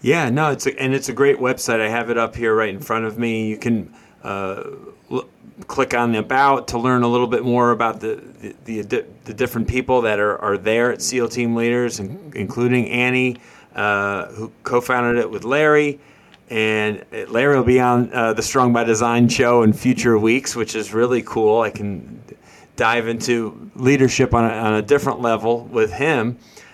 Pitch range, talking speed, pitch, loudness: 110-125 Hz, 195 wpm, 120 Hz, -19 LUFS